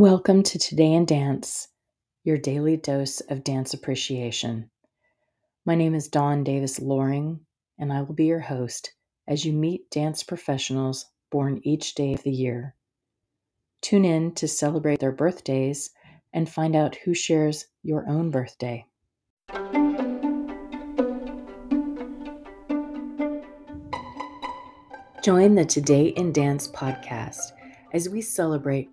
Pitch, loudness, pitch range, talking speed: 155 Hz, -25 LUFS, 135-185 Hz, 120 wpm